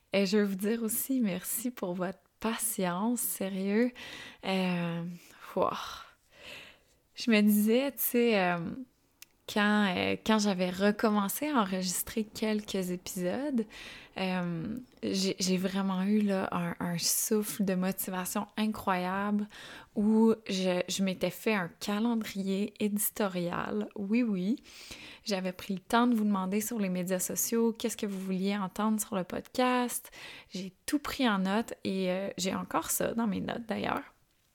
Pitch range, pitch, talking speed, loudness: 190-230 Hz, 205 Hz, 145 wpm, -31 LUFS